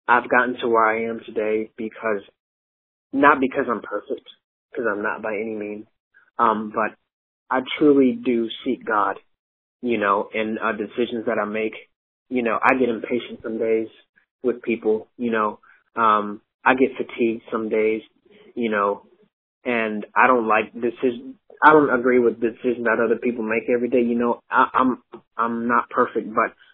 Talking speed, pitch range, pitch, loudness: 170 wpm, 110-120 Hz, 115 Hz, -21 LUFS